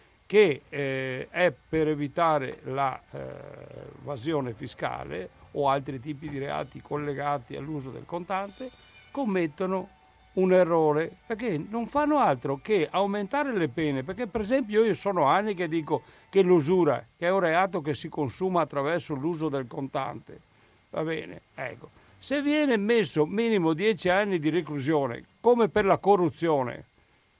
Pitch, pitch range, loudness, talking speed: 170 Hz, 145-200 Hz, -27 LUFS, 140 wpm